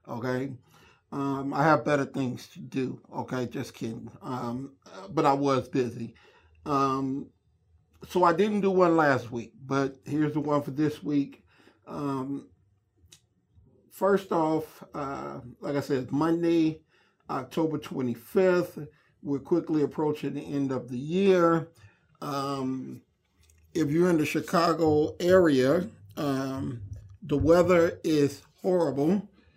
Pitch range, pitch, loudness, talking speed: 125-155 Hz, 140 Hz, -27 LUFS, 125 wpm